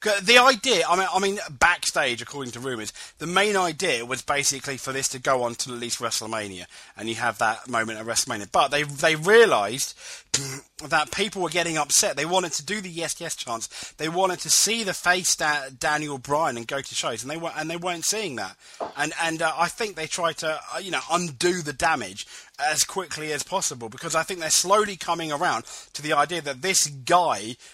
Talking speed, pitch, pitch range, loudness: 220 wpm, 155 Hz, 135-180 Hz, -23 LUFS